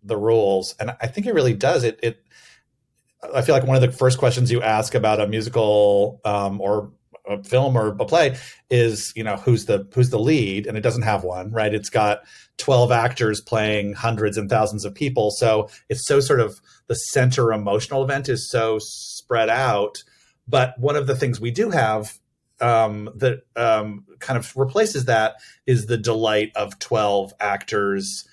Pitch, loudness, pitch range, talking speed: 115 Hz, -21 LUFS, 105-130 Hz, 185 wpm